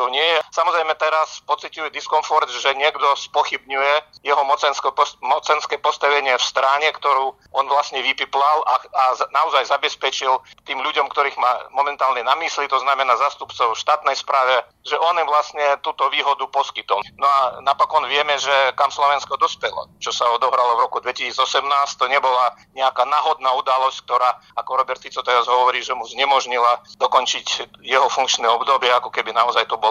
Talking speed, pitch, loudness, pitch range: 165 wpm, 140 Hz, -19 LUFS, 130-150 Hz